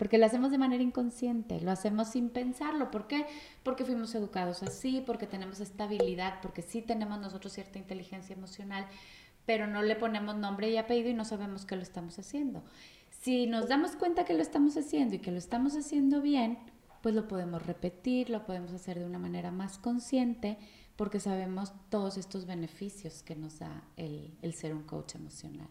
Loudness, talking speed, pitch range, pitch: -34 LUFS, 185 wpm, 190-245 Hz, 210 Hz